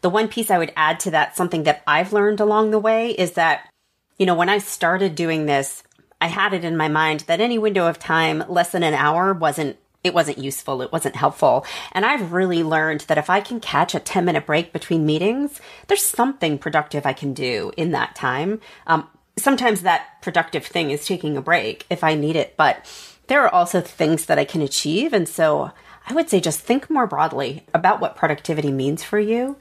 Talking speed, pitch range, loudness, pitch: 215 wpm, 155-210 Hz, -20 LUFS, 170 Hz